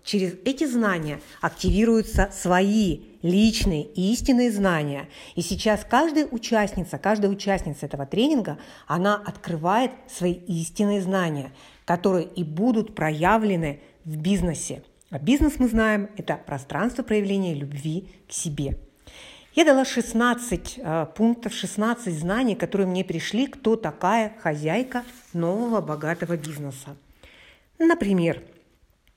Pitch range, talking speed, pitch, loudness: 165-225 Hz, 115 wpm, 190 Hz, -24 LUFS